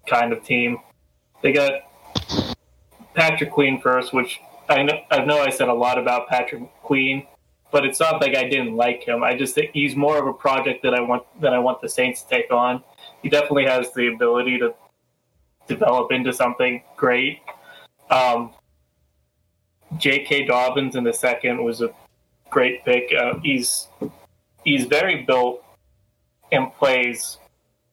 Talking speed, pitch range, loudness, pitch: 160 wpm, 120-140 Hz, -20 LUFS, 125 Hz